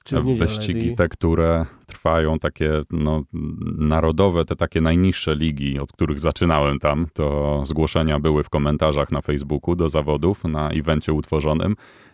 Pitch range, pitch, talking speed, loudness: 75-85 Hz, 80 Hz, 140 wpm, -21 LUFS